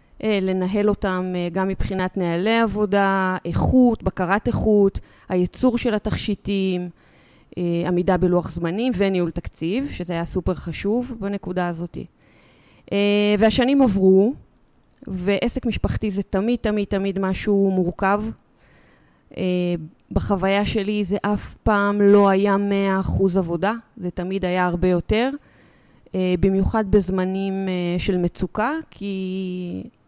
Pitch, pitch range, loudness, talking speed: 195 Hz, 185-210 Hz, -21 LUFS, 105 wpm